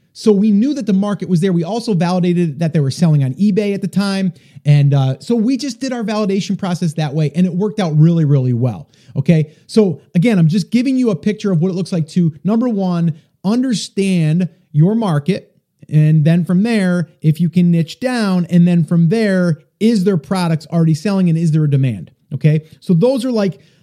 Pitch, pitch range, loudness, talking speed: 175 Hz, 160-205 Hz, -15 LUFS, 215 wpm